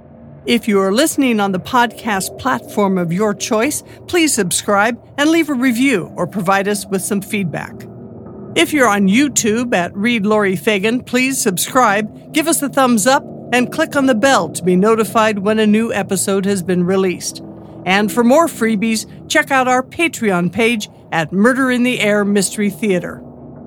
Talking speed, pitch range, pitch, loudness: 175 wpm, 195-255 Hz, 215 Hz, -15 LUFS